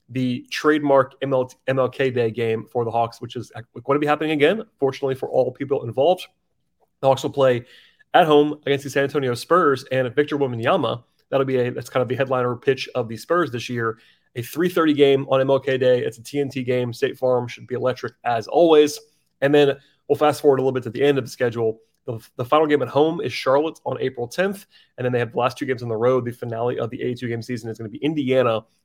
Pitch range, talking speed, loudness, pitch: 120-145 Hz, 240 wpm, -21 LUFS, 130 Hz